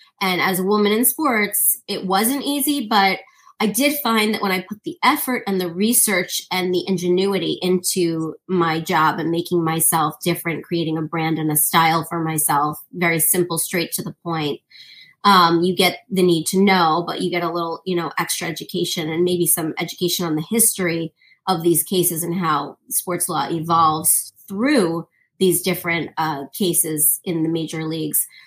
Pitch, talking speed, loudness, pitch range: 175 Hz, 180 wpm, -19 LUFS, 165-195 Hz